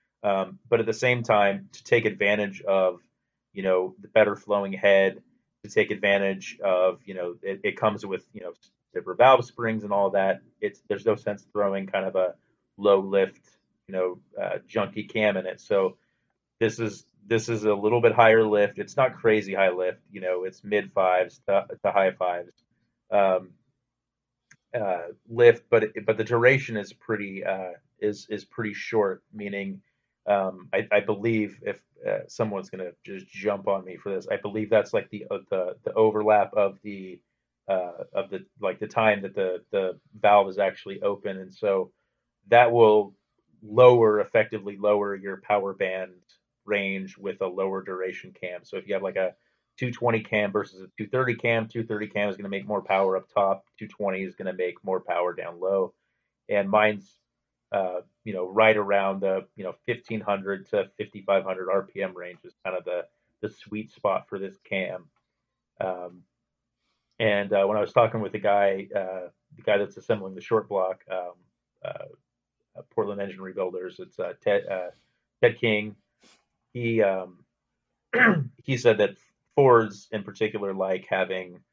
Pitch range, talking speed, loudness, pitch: 95-110 Hz, 175 wpm, -25 LUFS, 100 Hz